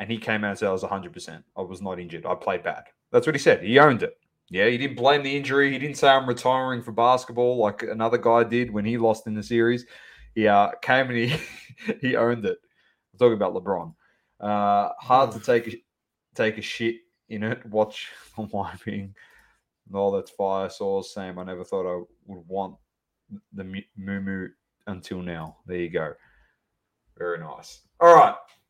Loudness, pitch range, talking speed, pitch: -23 LUFS, 95-125 Hz, 195 wpm, 110 Hz